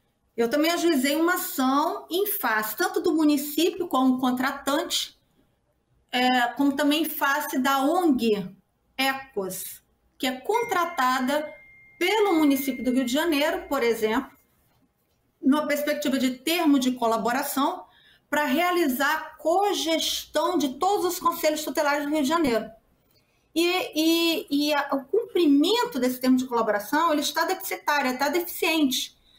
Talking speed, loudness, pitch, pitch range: 125 wpm, -24 LUFS, 295 Hz, 265-335 Hz